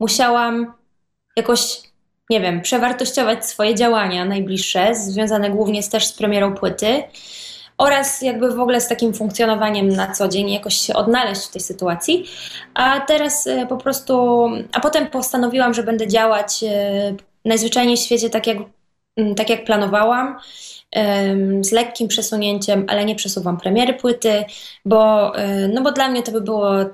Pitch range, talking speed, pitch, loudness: 205-245 Hz, 145 wpm, 220 Hz, -18 LUFS